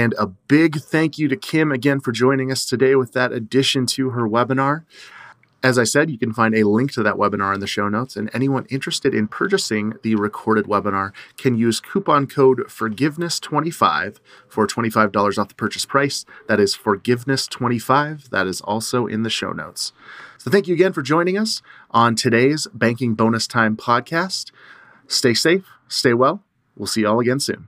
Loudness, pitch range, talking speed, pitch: -19 LUFS, 110-140 Hz, 185 wpm, 125 Hz